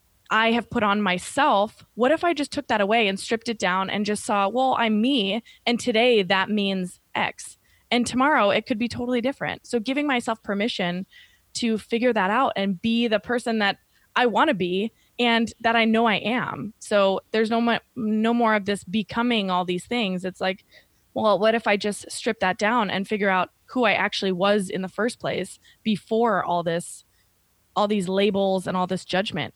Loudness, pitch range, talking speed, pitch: -23 LUFS, 190-235 Hz, 200 wpm, 210 Hz